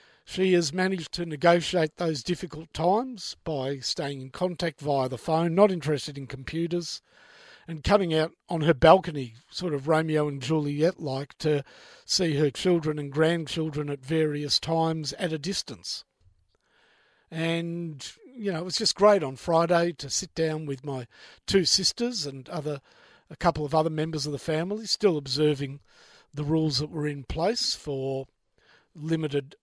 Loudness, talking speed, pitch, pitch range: -27 LUFS, 160 wpm, 160 Hz, 145-175 Hz